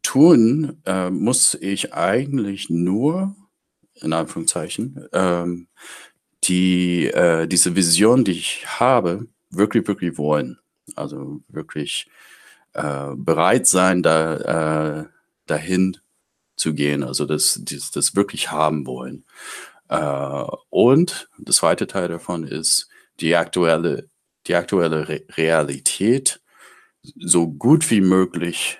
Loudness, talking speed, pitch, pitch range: -19 LUFS, 110 wpm, 85 Hz, 80-95 Hz